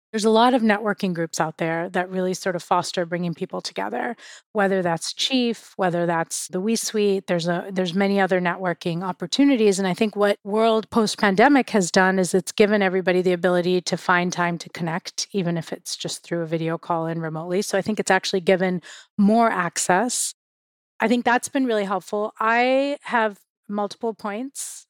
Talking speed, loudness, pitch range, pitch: 190 wpm, -22 LUFS, 180-215 Hz, 190 Hz